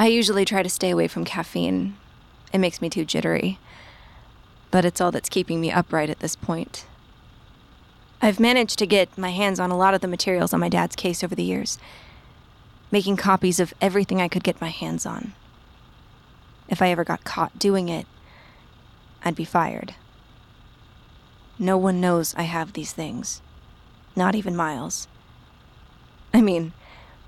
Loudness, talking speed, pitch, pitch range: -23 LUFS, 165 wpm, 180 Hz, 165-195 Hz